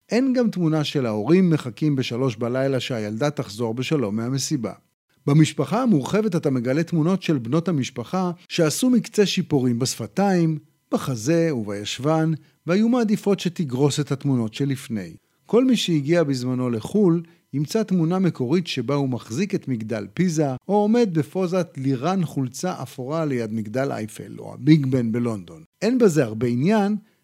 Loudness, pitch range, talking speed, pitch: -22 LUFS, 130-180 Hz, 140 wpm, 155 Hz